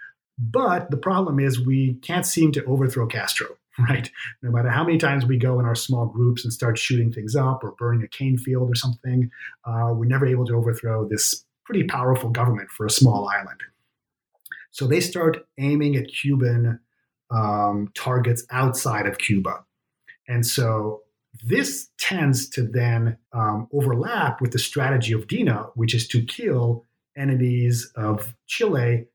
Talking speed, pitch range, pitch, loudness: 165 wpm, 115-135 Hz, 125 Hz, -22 LUFS